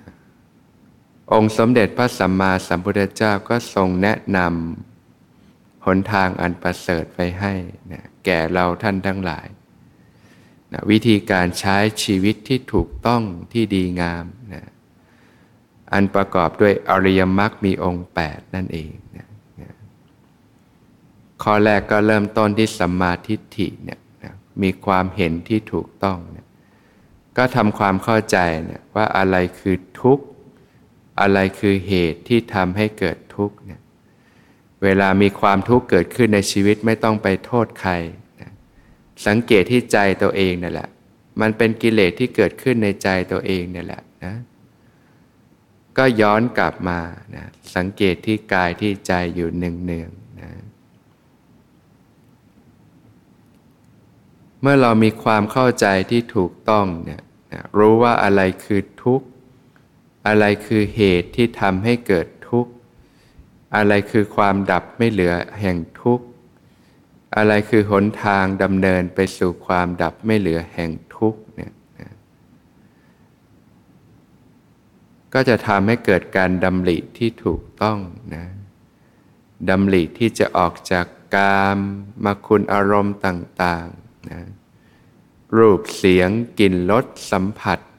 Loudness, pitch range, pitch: -18 LUFS, 90-110 Hz, 100 Hz